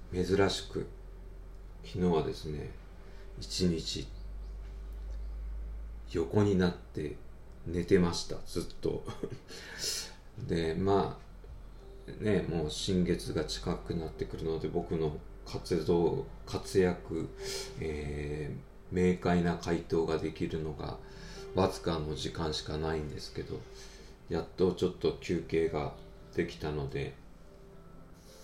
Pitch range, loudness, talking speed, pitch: 80-95 Hz, -34 LUFS, 190 characters per minute, 85 Hz